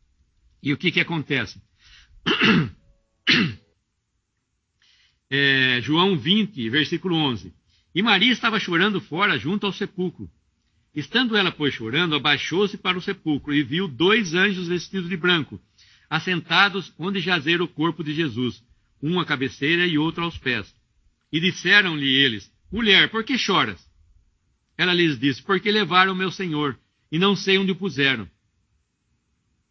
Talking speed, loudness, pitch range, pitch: 135 wpm, -21 LUFS, 115-185 Hz, 155 Hz